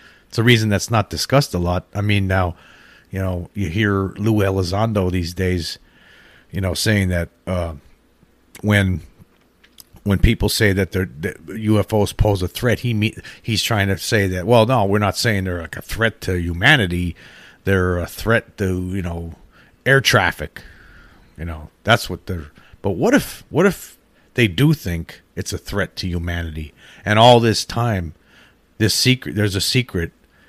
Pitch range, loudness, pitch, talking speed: 90-110 Hz, -19 LUFS, 95 Hz, 170 wpm